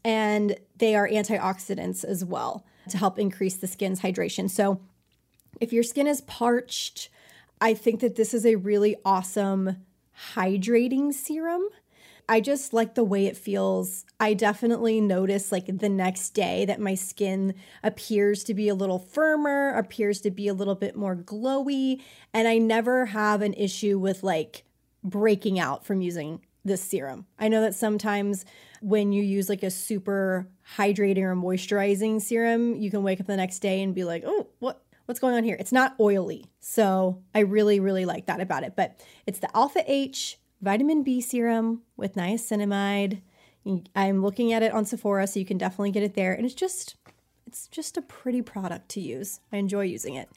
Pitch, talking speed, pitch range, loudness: 205 Hz, 180 wpm, 195-230 Hz, -26 LUFS